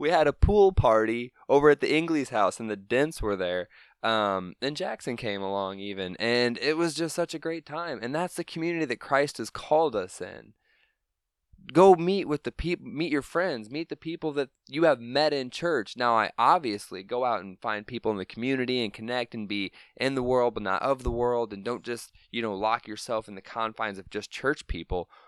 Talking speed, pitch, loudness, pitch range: 220 wpm, 120 Hz, -27 LUFS, 105-150 Hz